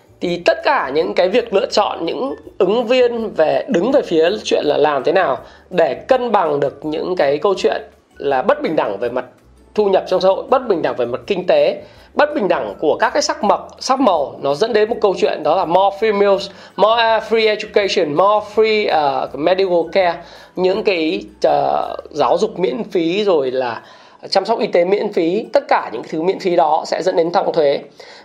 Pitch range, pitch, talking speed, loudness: 185-250 Hz, 215 Hz, 215 wpm, -16 LUFS